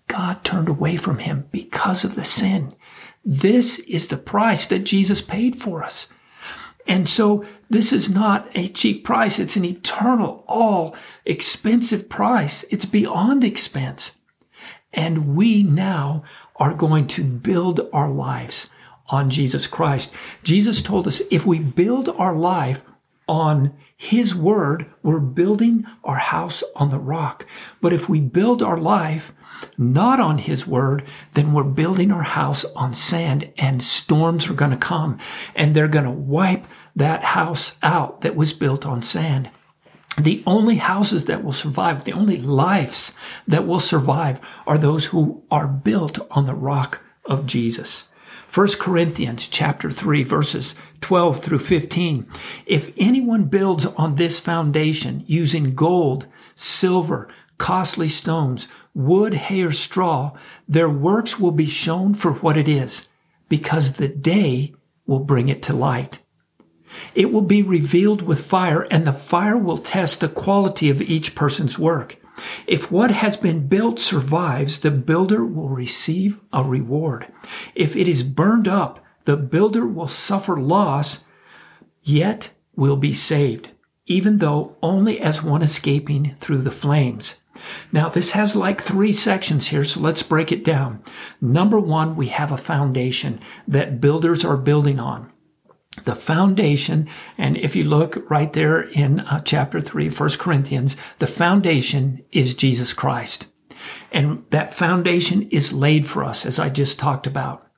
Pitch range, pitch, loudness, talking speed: 140-190 Hz, 160 Hz, -19 LUFS, 150 wpm